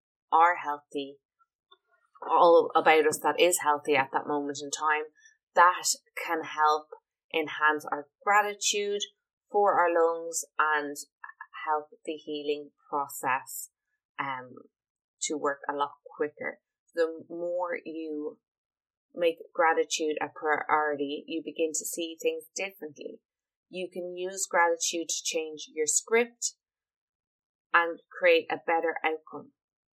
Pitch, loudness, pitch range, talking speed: 165 Hz, -28 LUFS, 155-245 Hz, 120 wpm